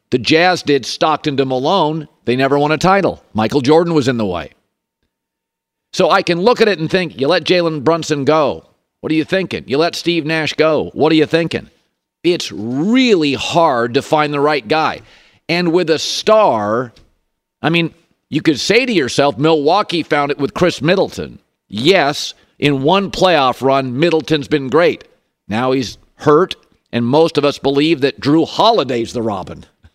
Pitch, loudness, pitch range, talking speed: 155 Hz, -15 LUFS, 135-170 Hz, 180 wpm